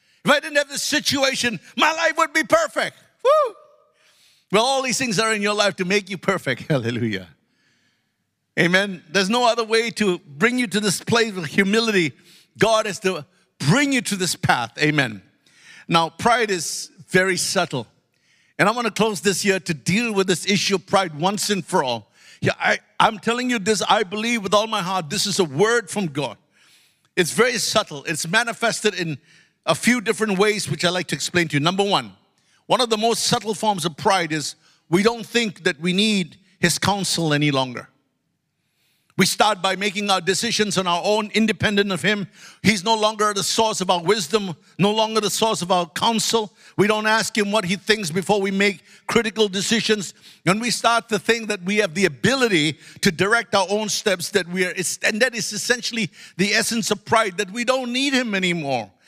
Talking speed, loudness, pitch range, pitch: 200 wpm, -20 LUFS, 180-225 Hz, 200 Hz